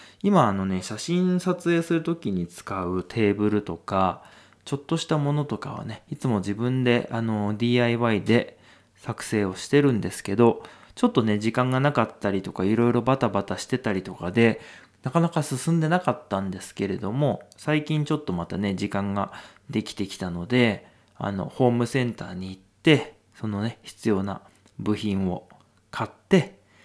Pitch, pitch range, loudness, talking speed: 115 Hz, 100-145 Hz, -25 LUFS, 330 characters per minute